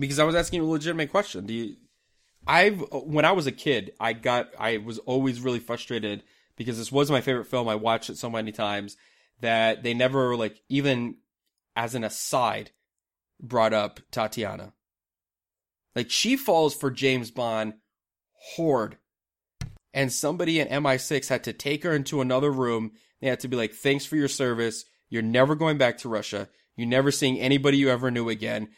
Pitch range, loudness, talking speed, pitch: 110-140 Hz, -26 LUFS, 180 wpm, 125 Hz